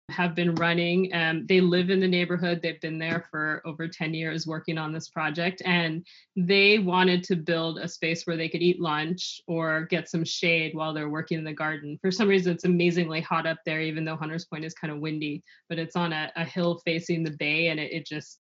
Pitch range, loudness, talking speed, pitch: 160-175 Hz, -26 LUFS, 235 wpm, 165 Hz